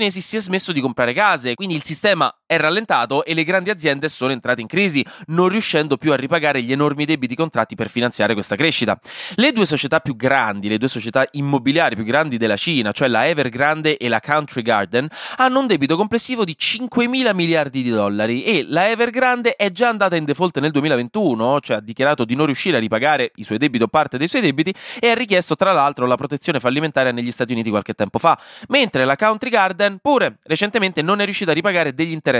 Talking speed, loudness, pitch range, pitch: 215 wpm, -18 LUFS, 130-200 Hz, 155 Hz